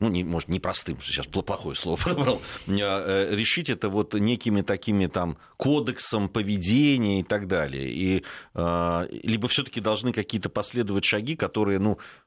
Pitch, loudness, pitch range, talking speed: 100 Hz, -26 LUFS, 90-110 Hz, 135 wpm